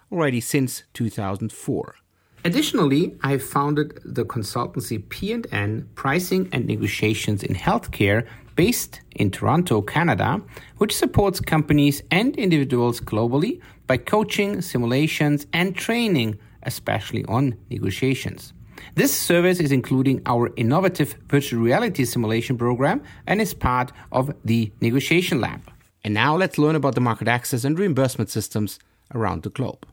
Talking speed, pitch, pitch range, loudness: 125 wpm, 130 Hz, 115-150 Hz, -22 LUFS